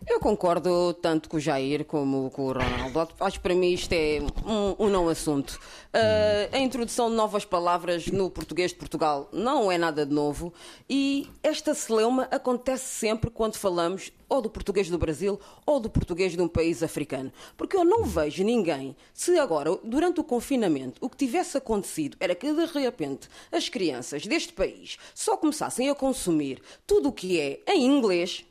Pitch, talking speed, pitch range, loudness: 190 Hz, 180 wpm, 160-260 Hz, -26 LUFS